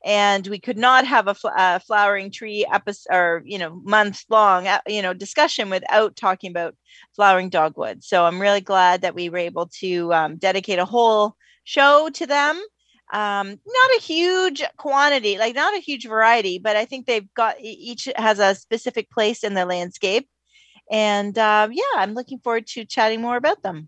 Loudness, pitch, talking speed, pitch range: -19 LUFS, 215 Hz, 185 wpm, 190-240 Hz